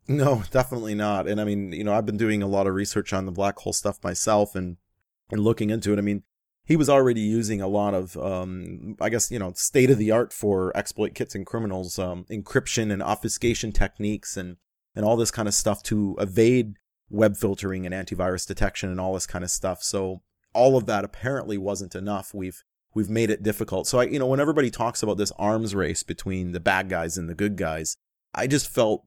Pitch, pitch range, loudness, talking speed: 105 Hz, 95-110 Hz, -25 LUFS, 225 wpm